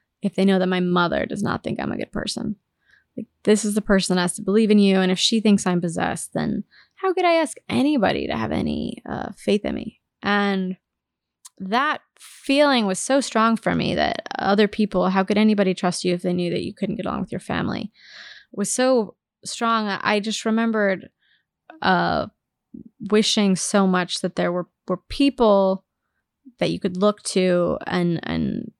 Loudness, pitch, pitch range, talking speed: -21 LUFS, 200 Hz, 185-225 Hz, 190 wpm